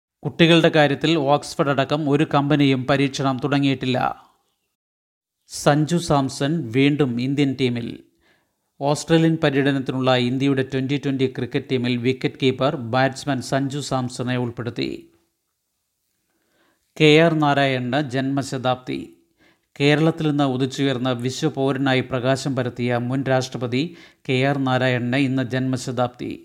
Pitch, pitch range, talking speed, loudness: 135 Hz, 130-145 Hz, 100 wpm, -20 LUFS